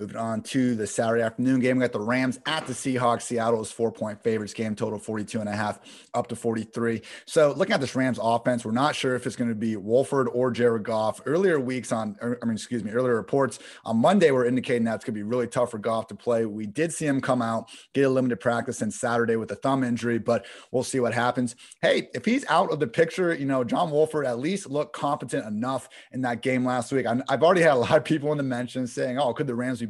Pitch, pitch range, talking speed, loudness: 120 Hz, 115-130 Hz, 255 wpm, -25 LUFS